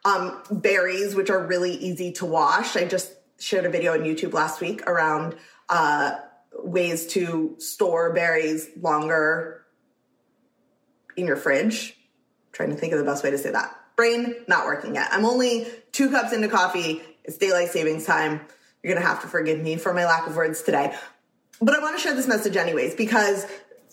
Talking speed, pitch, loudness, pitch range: 185 wpm, 190 Hz, -23 LUFS, 165-235 Hz